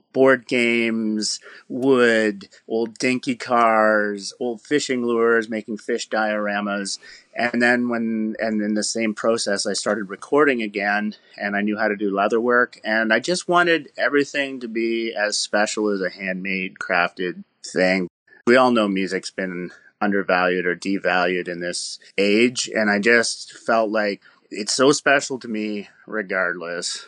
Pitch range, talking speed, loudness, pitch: 100-120 Hz, 150 wpm, -21 LUFS, 110 Hz